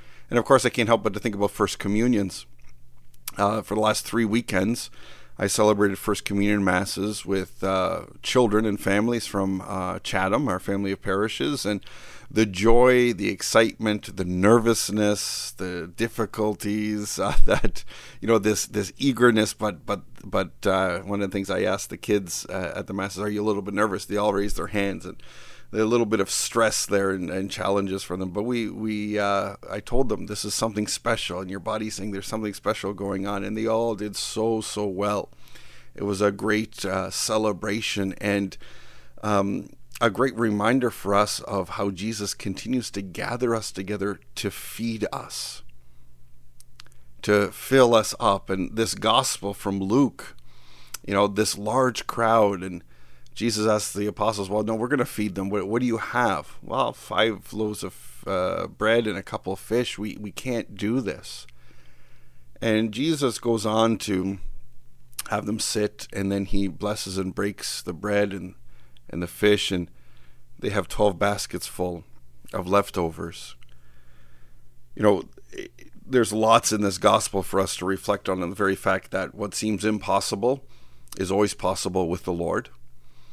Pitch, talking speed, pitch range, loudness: 100 Hz, 175 wpm, 95-110 Hz, -25 LUFS